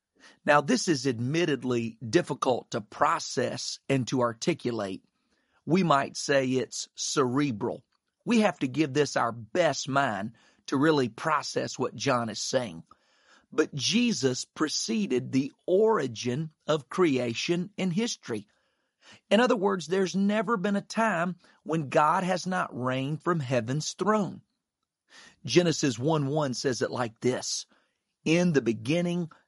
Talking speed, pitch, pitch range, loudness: 130 wpm, 155 Hz, 130-185 Hz, -28 LUFS